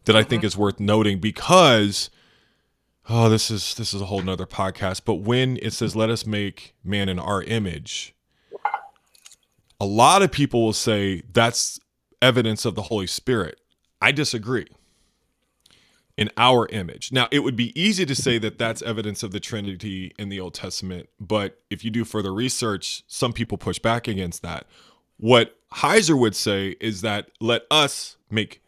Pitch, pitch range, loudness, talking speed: 110 Hz, 100-120 Hz, -22 LUFS, 170 wpm